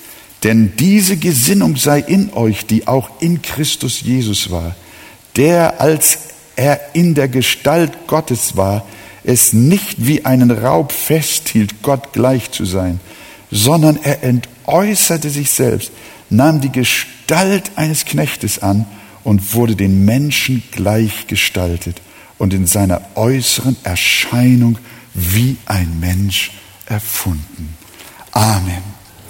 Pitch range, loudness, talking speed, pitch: 100-145 Hz, -14 LUFS, 115 wpm, 120 Hz